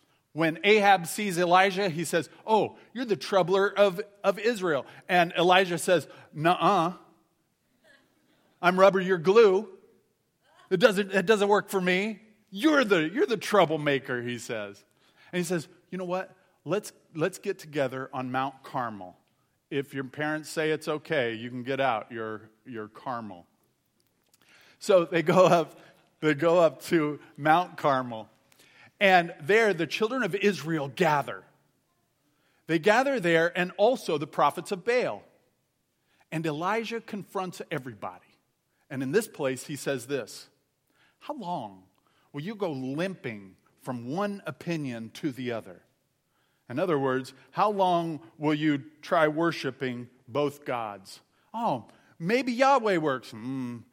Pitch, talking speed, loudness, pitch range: 170 Hz, 140 wpm, -27 LUFS, 135-195 Hz